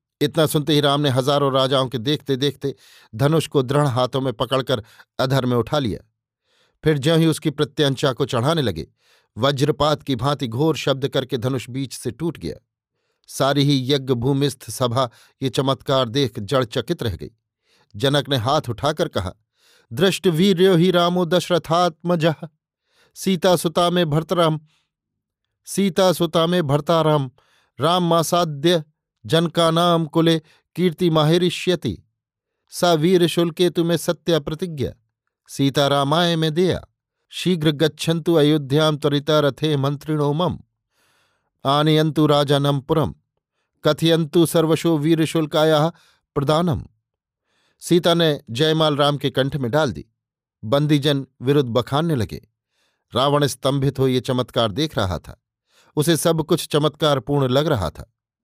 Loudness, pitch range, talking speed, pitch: -20 LUFS, 130-165 Hz, 125 wpm, 145 Hz